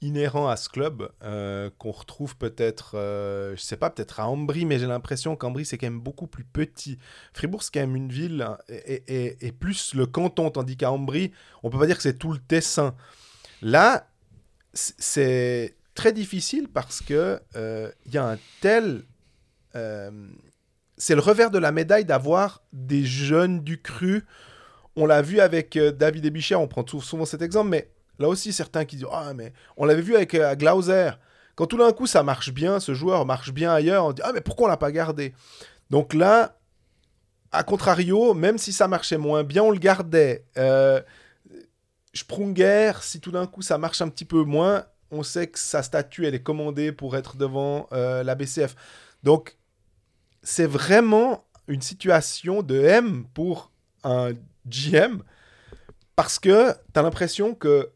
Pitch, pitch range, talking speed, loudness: 150 Hz, 130-175 Hz, 185 wpm, -23 LUFS